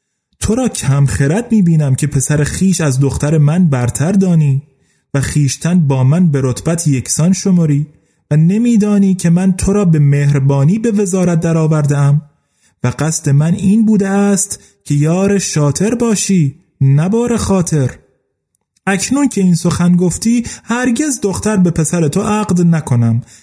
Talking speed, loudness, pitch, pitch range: 150 wpm, -13 LUFS, 165 Hz, 145-195 Hz